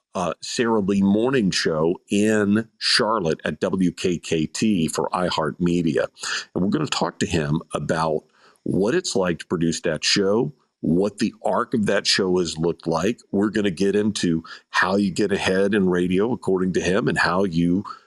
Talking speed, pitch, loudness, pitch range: 175 wpm, 95 Hz, -22 LUFS, 85-100 Hz